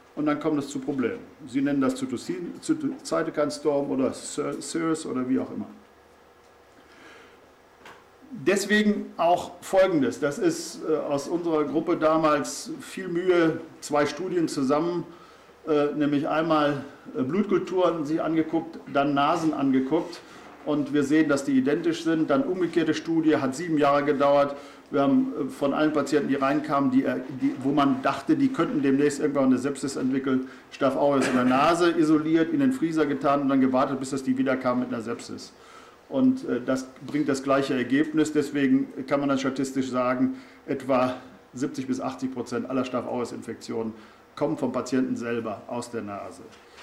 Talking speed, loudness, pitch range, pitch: 150 wpm, -25 LUFS, 135-165 Hz, 145 Hz